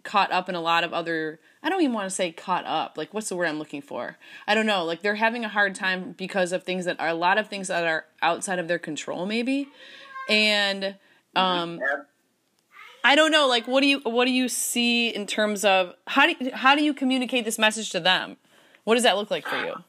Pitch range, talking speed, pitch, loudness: 180-250 Hz, 245 wpm, 205 Hz, -23 LUFS